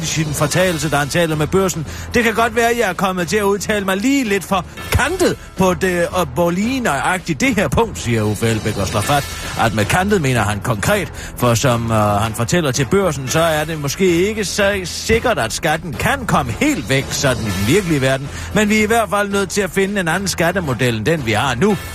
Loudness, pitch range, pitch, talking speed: -17 LUFS, 130-200 Hz, 170 Hz, 240 wpm